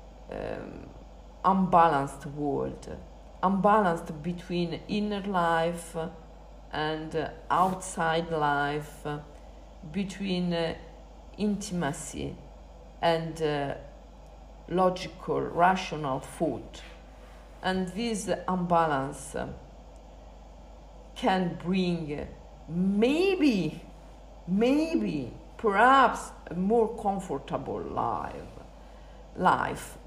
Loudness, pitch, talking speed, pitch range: -28 LUFS, 170 Hz, 70 wpm, 145-185 Hz